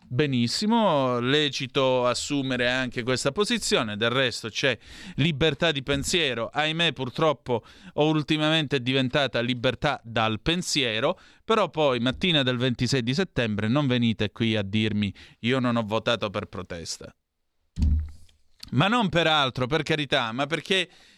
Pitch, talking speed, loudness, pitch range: 130 Hz, 135 wpm, -25 LUFS, 115-155 Hz